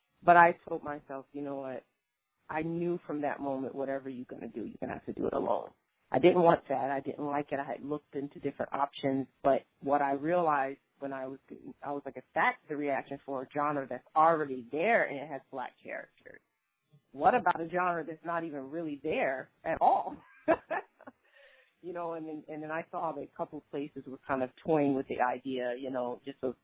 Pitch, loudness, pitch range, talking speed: 145 Hz, -32 LUFS, 135-165 Hz, 225 wpm